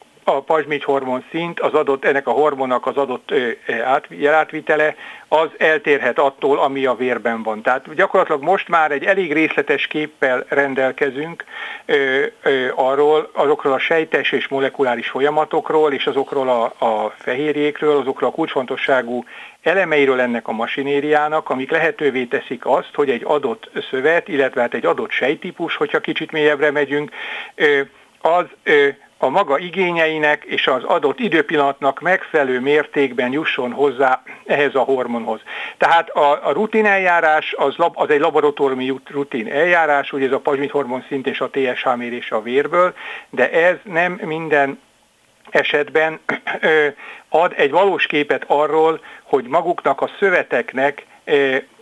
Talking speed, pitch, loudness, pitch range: 140 wpm, 150 Hz, -18 LUFS, 135-165 Hz